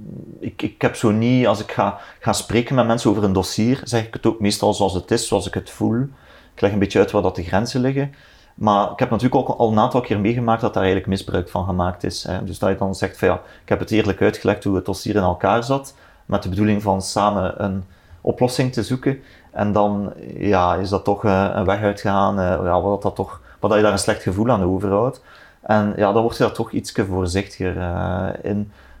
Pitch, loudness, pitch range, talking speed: 100 Hz, -20 LUFS, 95-115 Hz, 235 wpm